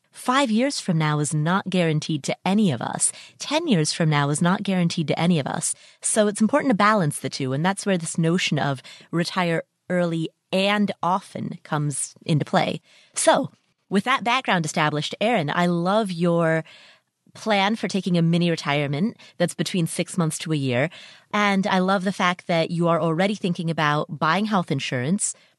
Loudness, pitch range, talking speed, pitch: -22 LUFS, 160-200 Hz, 185 wpm, 175 Hz